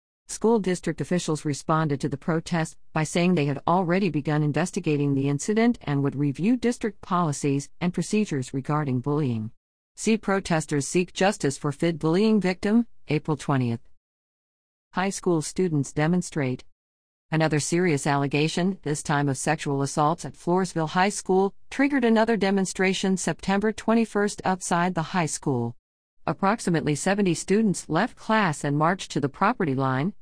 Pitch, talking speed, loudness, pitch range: 160 Hz, 140 wpm, -25 LUFS, 145-190 Hz